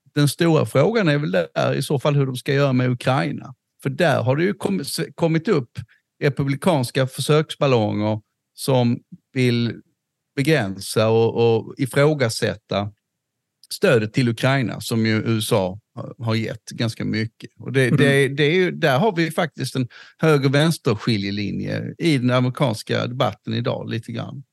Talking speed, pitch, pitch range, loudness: 150 wpm, 135 Hz, 115-150 Hz, -21 LUFS